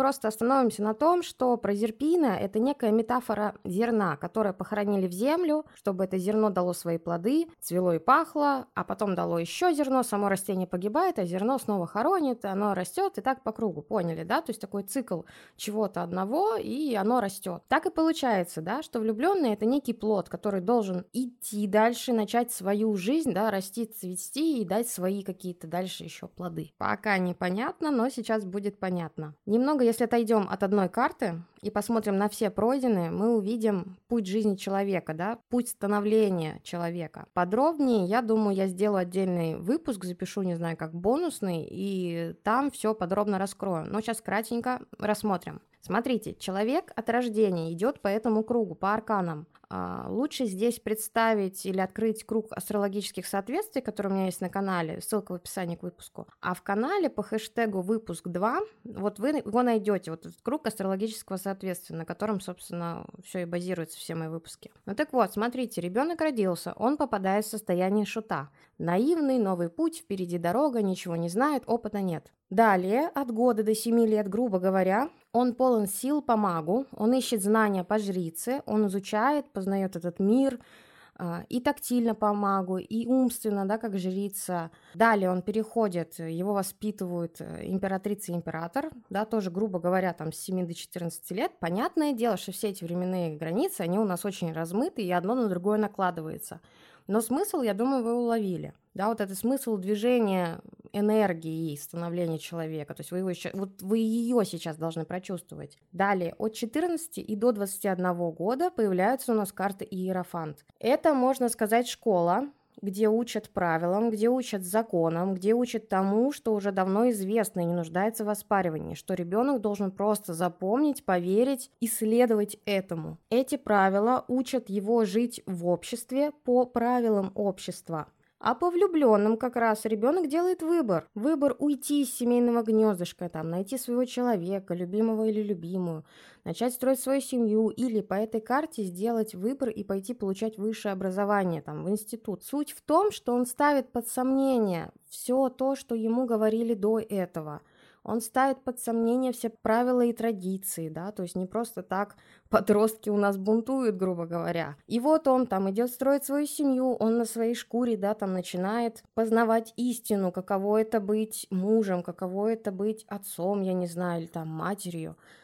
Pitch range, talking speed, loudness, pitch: 185-235 Hz, 165 wpm, -28 LUFS, 210 Hz